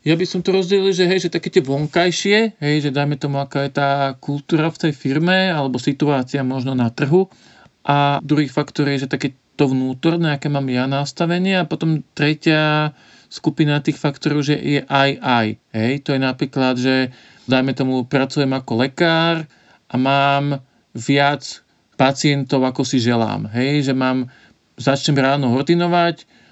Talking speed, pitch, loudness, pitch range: 165 wpm, 145 Hz, -18 LUFS, 130-160 Hz